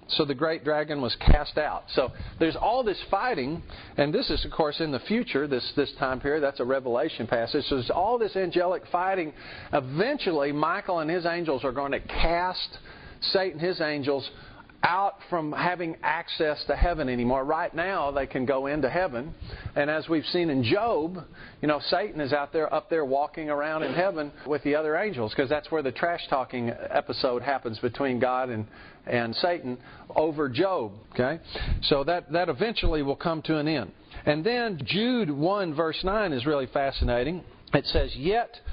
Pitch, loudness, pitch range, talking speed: 150 Hz, -27 LUFS, 135-170 Hz, 185 wpm